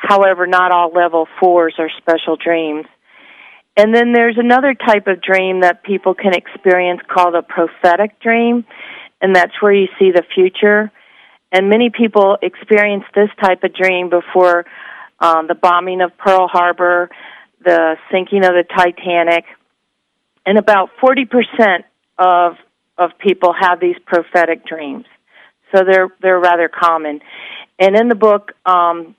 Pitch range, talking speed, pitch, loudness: 175-205 Hz, 145 wpm, 185 Hz, -13 LUFS